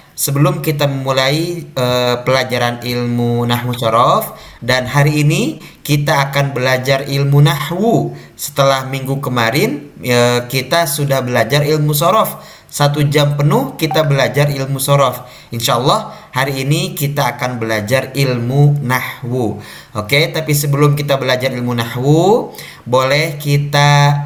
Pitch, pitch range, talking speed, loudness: 140 Hz, 125-145 Hz, 125 wpm, -14 LUFS